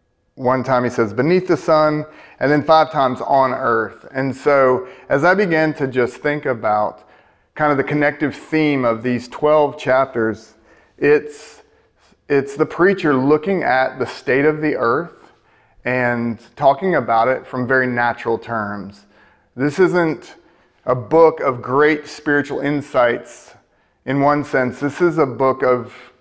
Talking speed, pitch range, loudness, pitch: 150 wpm, 125-150 Hz, -17 LUFS, 135 Hz